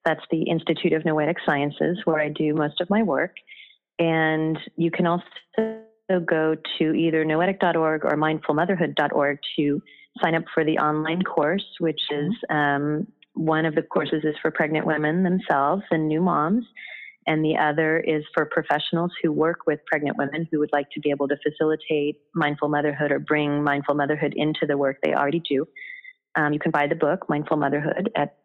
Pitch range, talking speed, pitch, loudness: 150-170 Hz, 180 wpm, 155 Hz, -23 LUFS